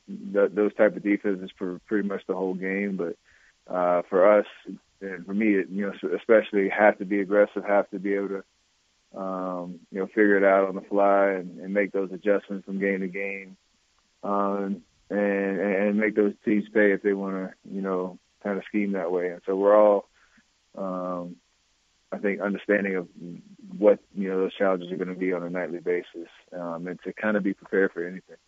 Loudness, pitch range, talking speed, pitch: -25 LUFS, 90-100 Hz, 205 wpm, 95 Hz